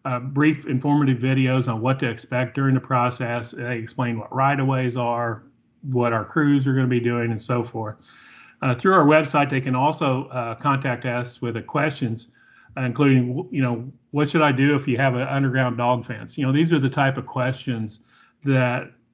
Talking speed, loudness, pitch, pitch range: 205 wpm, -22 LUFS, 130 Hz, 120-135 Hz